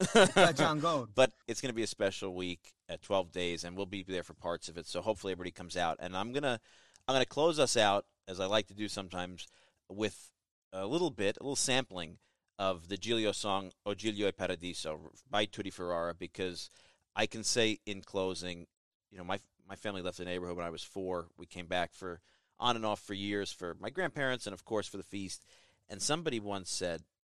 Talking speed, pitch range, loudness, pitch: 210 wpm, 90-105 Hz, -35 LUFS, 95 Hz